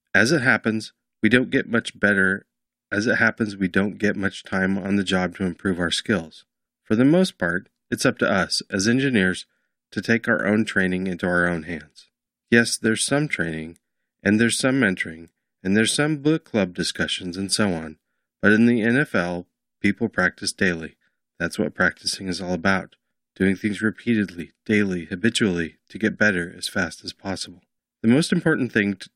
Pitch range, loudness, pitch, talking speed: 90-115 Hz, -22 LUFS, 100 Hz, 185 wpm